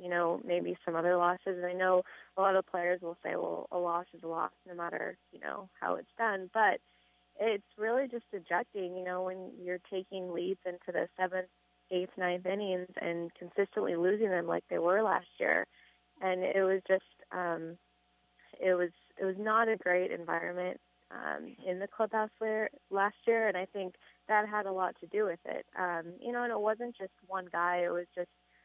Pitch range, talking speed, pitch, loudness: 175-200 Hz, 200 wpm, 185 Hz, -34 LUFS